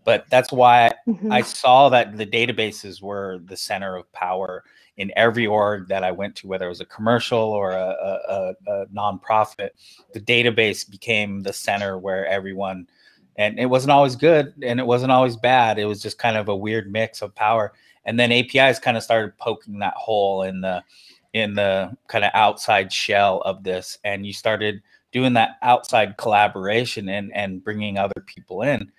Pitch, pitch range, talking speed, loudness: 105 Hz, 100-120 Hz, 185 wpm, -20 LUFS